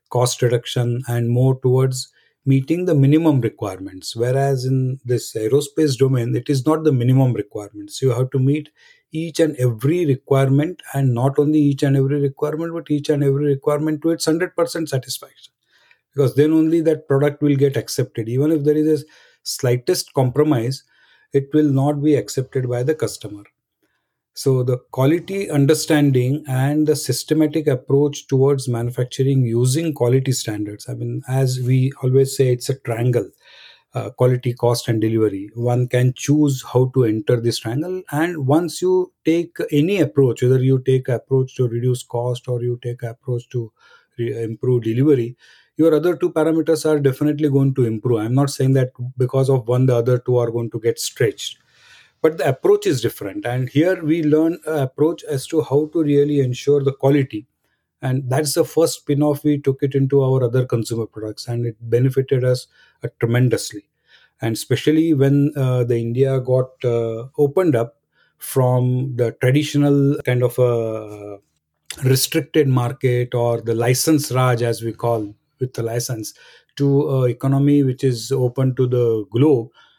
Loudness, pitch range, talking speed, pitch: -19 LUFS, 120-150 Hz, 165 wpm, 130 Hz